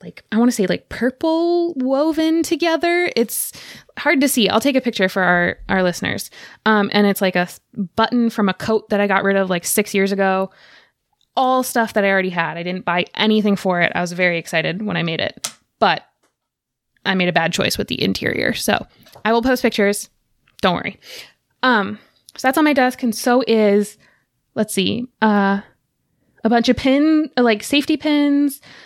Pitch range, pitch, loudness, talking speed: 195-255 Hz, 215 Hz, -18 LUFS, 195 wpm